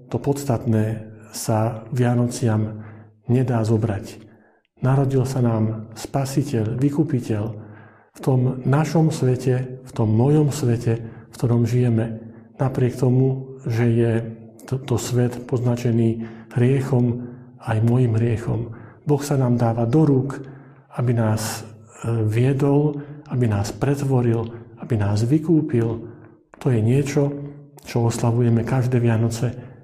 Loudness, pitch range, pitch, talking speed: -21 LUFS, 115-130 Hz, 120 Hz, 115 wpm